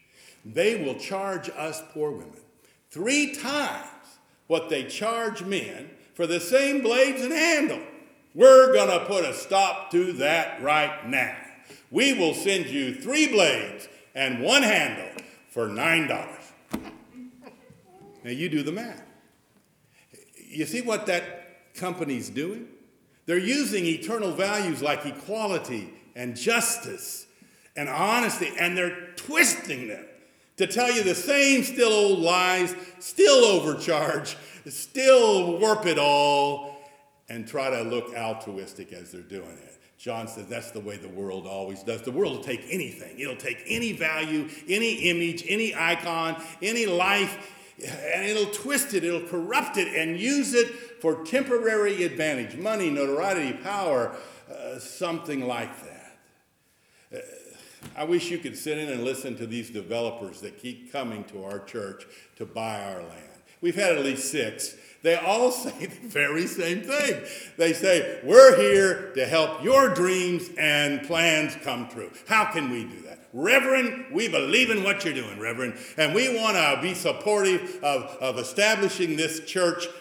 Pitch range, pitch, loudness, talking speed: 150-235 Hz, 180 Hz, -24 LUFS, 150 wpm